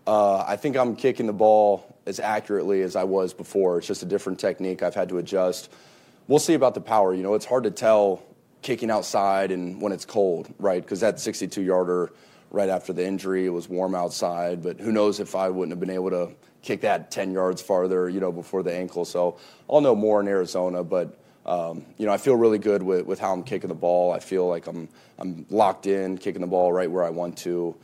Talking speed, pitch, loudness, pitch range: 235 wpm, 95 Hz, -24 LUFS, 90-100 Hz